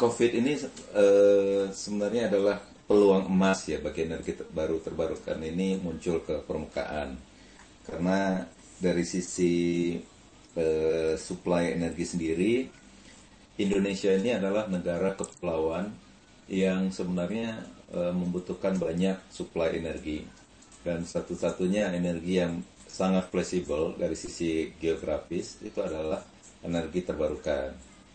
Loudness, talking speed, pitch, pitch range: -29 LUFS, 100 wpm, 90 Hz, 80-95 Hz